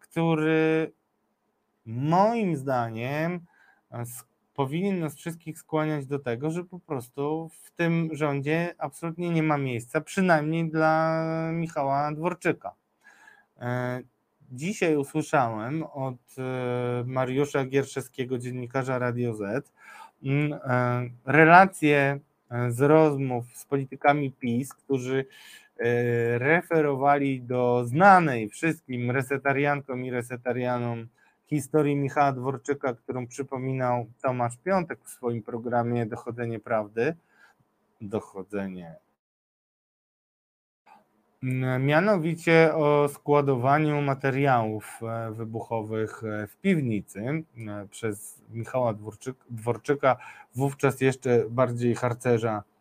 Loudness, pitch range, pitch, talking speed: -26 LUFS, 120-155 Hz, 135 Hz, 80 wpm